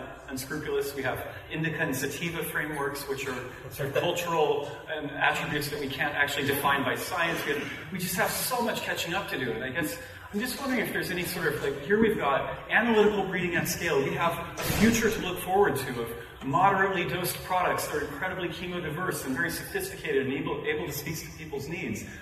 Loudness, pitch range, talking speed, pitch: -29 LUFS, 140-195 Hz, 215 wpm, 165 Hz